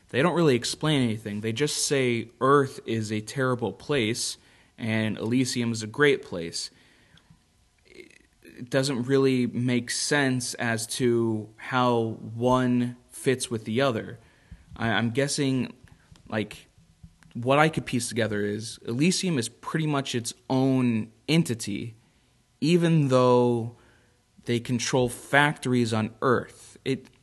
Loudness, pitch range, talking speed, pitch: -26 LUFS, 115-135 Hz, 125 wpm, 120 Hz